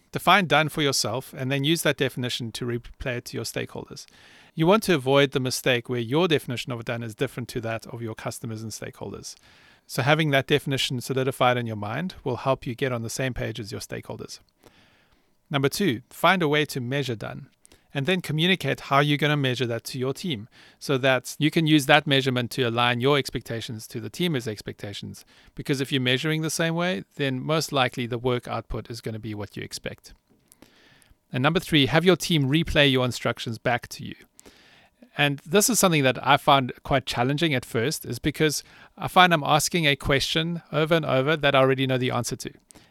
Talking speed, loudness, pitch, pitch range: 210 wpm, -24 LUFS, 135 Hz, 120-150 Hz